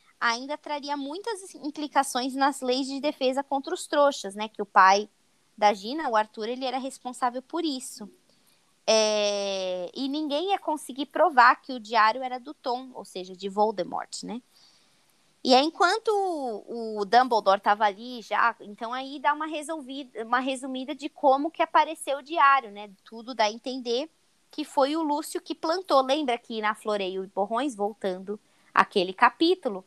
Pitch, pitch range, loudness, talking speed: 255 Hz, 215-295 Hz, -26 LUFS, 165 wpm